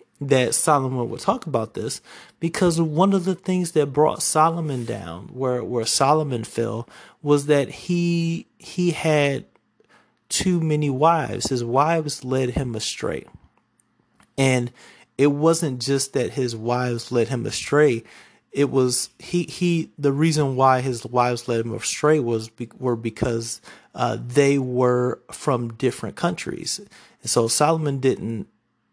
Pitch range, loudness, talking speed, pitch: 120-155 Hz, -22 LUFS, 140 wpm, 135 Hz